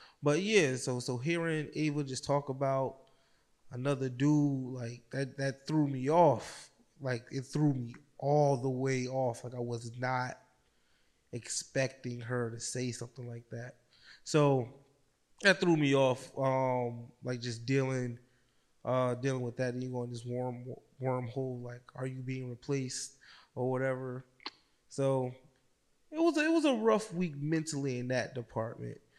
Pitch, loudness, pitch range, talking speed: 130 Hz, -33 LUFS, 125-140 Hz, 150 wpm